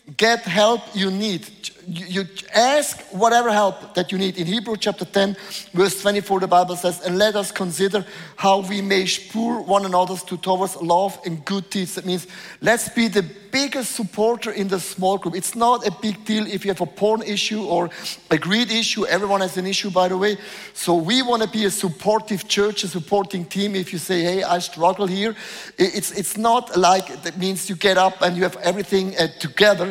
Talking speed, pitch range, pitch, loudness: 205 wpm, 185-210 Hz, 195 Hz, -20 LUFS